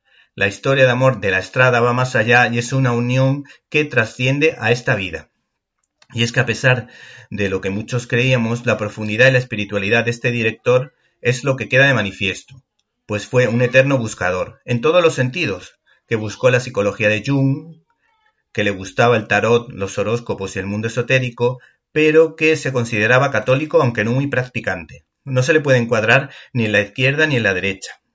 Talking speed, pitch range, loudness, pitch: 195 wpm, 110-130 Hz, -17 LUFS, 125 Hz